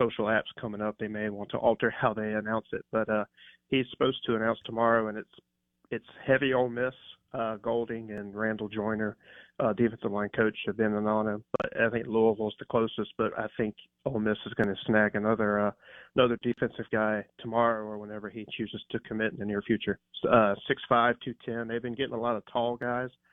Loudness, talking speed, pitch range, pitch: -30 LUFS, 215 wpm, 105-120 Hz, 110 Hz